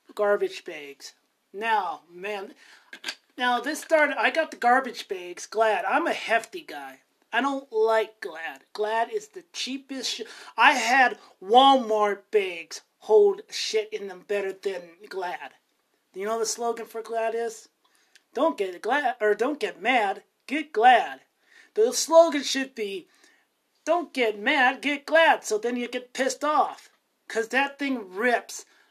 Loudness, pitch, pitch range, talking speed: -24 LUFS, 265 Hz, 225-360 Hz, 150 wpm